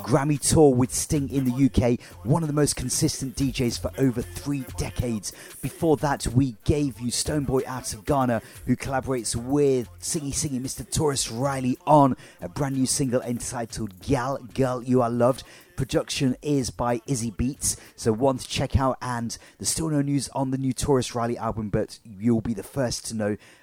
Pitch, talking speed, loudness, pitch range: 125 Hz, 185 wpm, -25 LUFS, 115-140 Hz